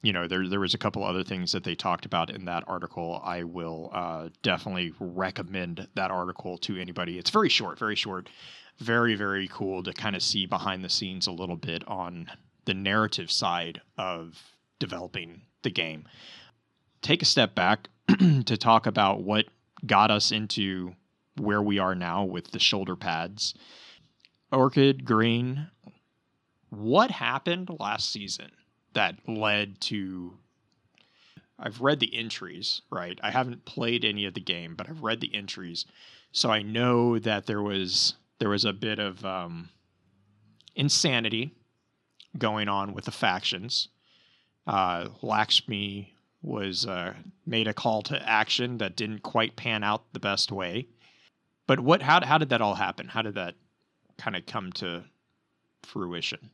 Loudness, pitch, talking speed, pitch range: -27 LUFS, 105 Hz, 155 wpm, 95-115 Hz